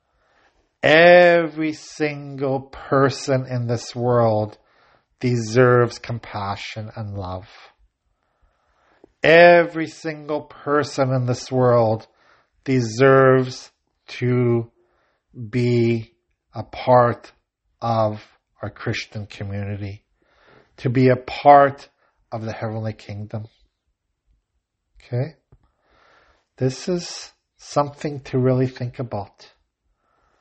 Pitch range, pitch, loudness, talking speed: 110-135 Hz, 125 Hz, -19 LUFS, 80 wpm